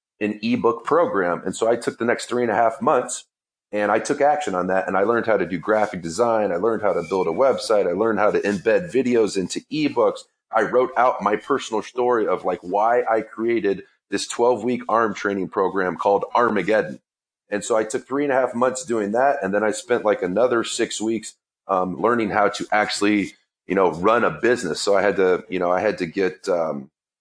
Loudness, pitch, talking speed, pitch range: -21 LUFS, 110 Hz, 225 wpm, 100-130 Hz